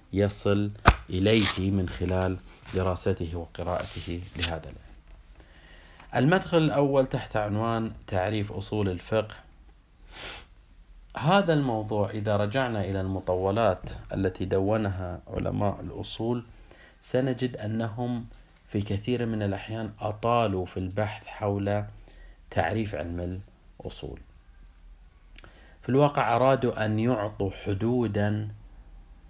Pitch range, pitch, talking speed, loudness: 90-110 Hz, 100 Hz, 90 wpm, -28 LUFS